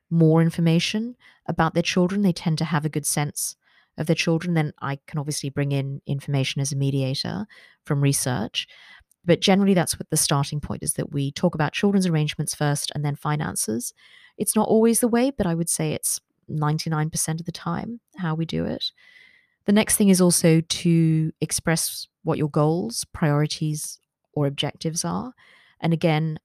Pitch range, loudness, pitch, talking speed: 150-180 Hz, -23 LUFS, 160 Hz, 180 wpm